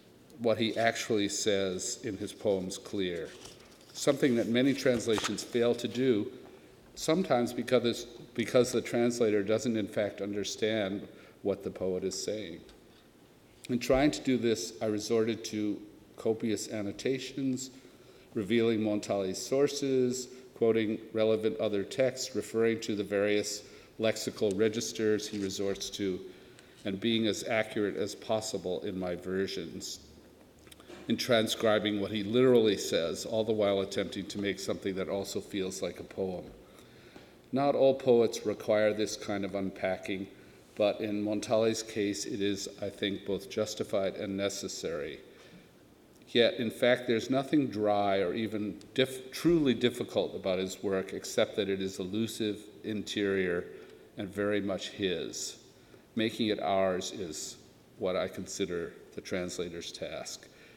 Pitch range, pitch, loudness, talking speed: 100-120 Hz, 110 Hz, -31 LUFS, 135 wpm